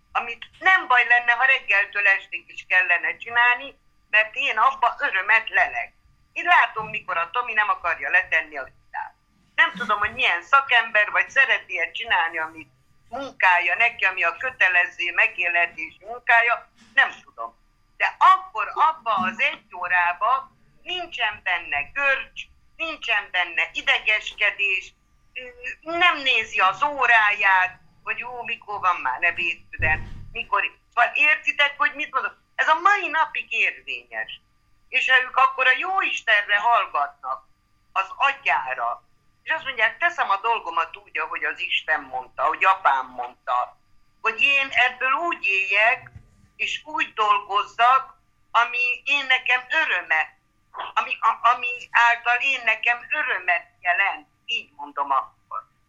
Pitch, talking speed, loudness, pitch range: 235 Hz, 135 wpm, -20 LUFS, 190-275 Hz